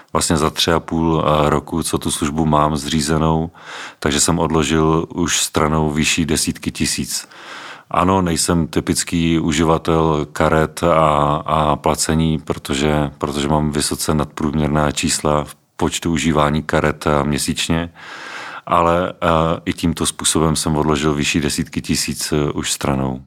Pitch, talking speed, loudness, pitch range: 80 Hz, 125 wpm, -17 LUFS, 75-80 Hz